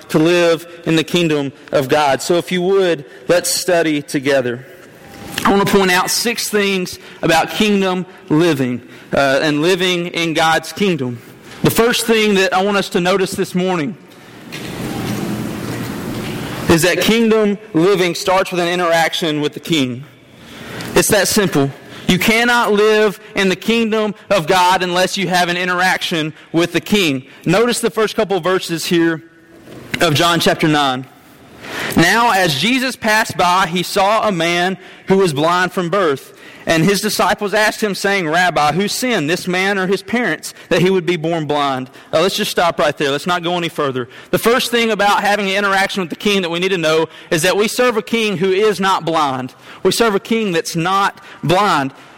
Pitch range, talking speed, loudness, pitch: 165-200 Hz, 185 wpm, -15 LUFS, 180 Hz